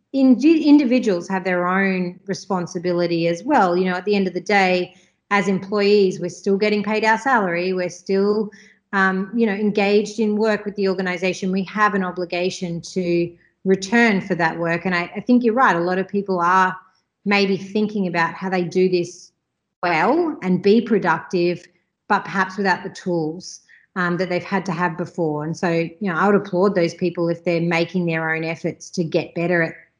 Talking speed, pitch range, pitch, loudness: 190 wpm, 175-205 Hz, 185 Hz, -20 LUFS